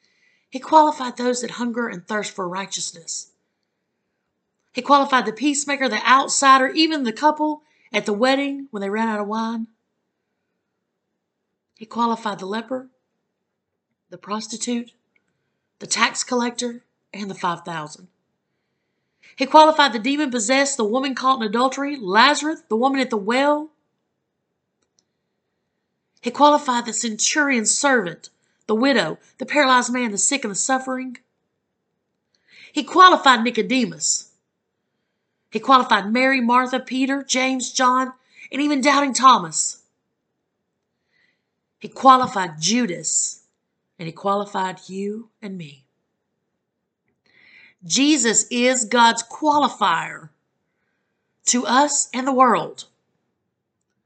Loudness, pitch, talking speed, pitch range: -19 LUFS, 245 Hz, 115 wpm, 215-270 Hz